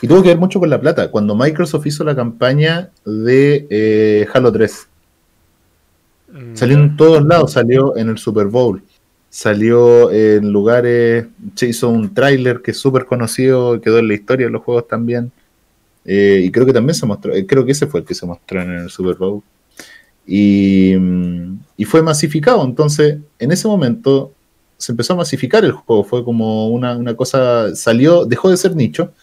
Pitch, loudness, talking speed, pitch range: 120 Hz, -13 LUFS, 185 wpm, 105-140 Hz